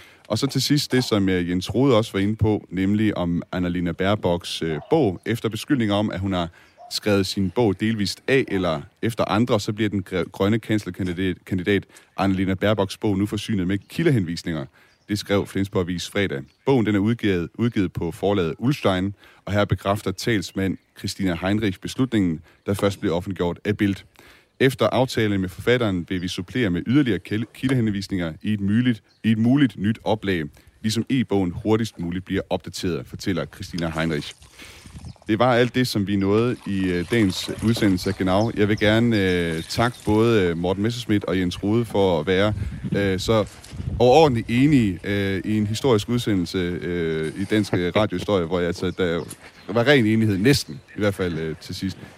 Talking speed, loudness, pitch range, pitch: 170 wpm, -22 LUFS, 90-110 Hz, 100 Hz